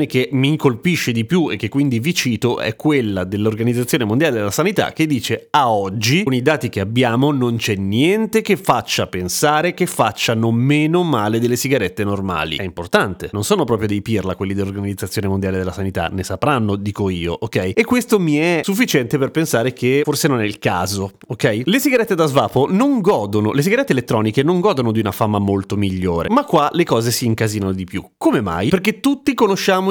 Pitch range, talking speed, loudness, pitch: 100-155 Hz, 195 wpm, -17 LUFS, 120 Hz